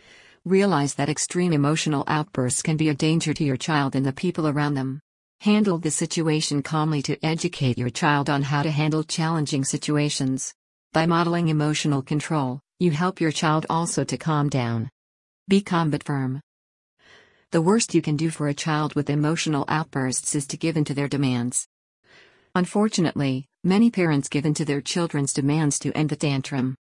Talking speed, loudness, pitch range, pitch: 175 wpm, -23 LUFS, 140-165 Hz, 150 Hz